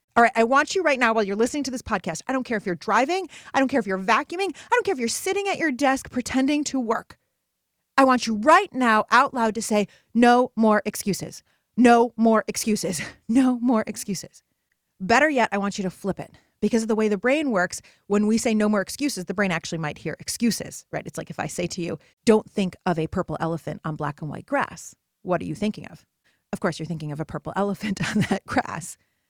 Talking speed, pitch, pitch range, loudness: 240 wpm, 220 Hz, 185-255 Hz, -23 LUFS